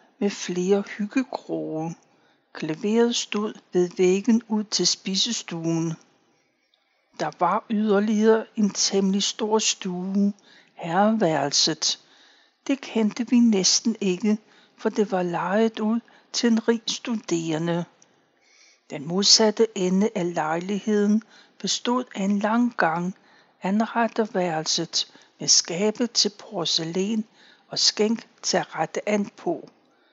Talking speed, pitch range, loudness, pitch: 110 wpm, 185-225 Hz, -23 LUFS, 210 Hz